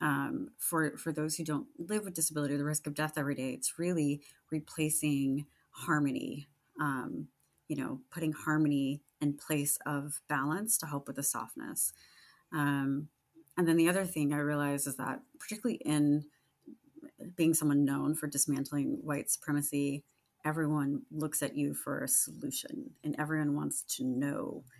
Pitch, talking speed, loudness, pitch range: 150 Hz, 155 wpm, -33 LUFS, 140-155 Hz